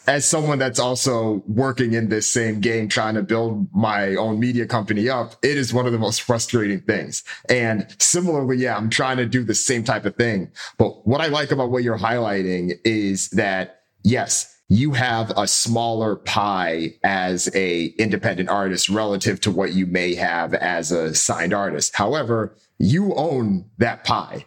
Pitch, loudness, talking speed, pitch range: 110 Hz, -20 LUFS, 175 wpm, 100-125 Hz